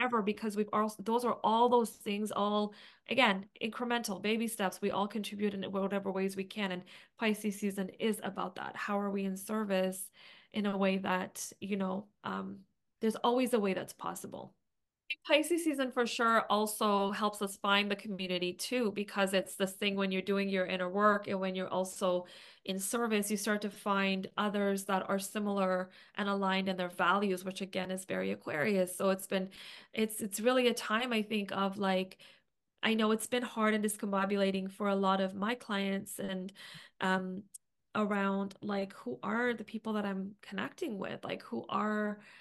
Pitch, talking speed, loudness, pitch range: 200 Hz, 185 wpm, -34 LUFS, 190-215 Hz